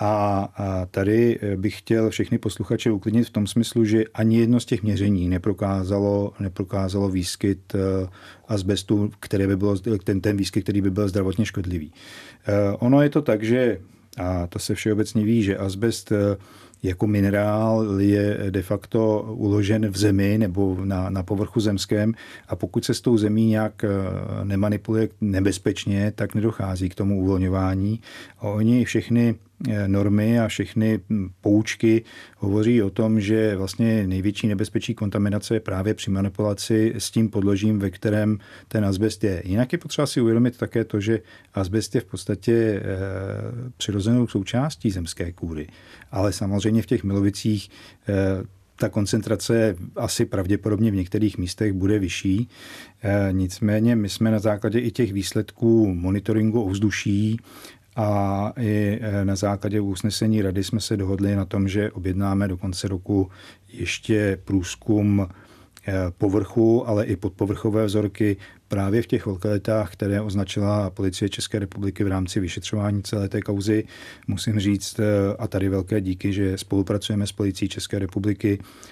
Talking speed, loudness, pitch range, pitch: 145 wpm, -23 LUFS, 100-110 Hz, 105 Hz